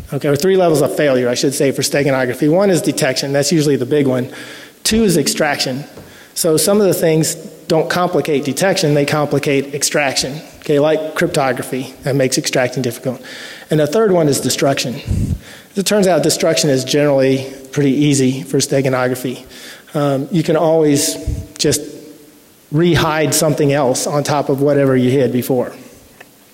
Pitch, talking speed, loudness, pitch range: 145 Hz, 160 wpm, -15 LUFS, 135-160 Hz